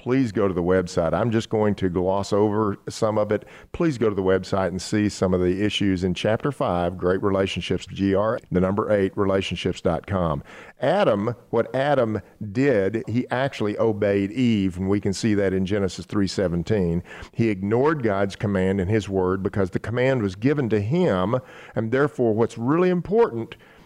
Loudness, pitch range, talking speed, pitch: -23 LUFS, 95-115 Hz, 175 wpm, 105 Hz